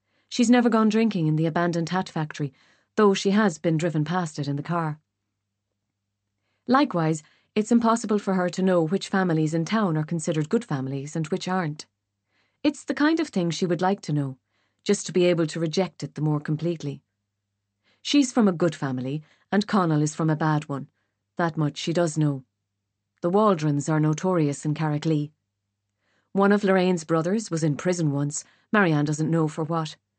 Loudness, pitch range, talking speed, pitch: -24 LUFS, 140-185 Hz, 185 wpm, 160 Hz